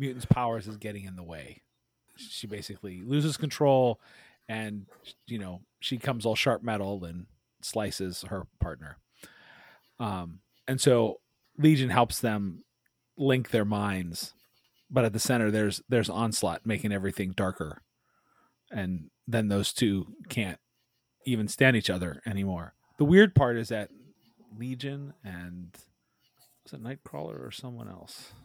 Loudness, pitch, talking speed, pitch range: -29 LUFS, 110 Hz, 135 wpm, 95-125 Hz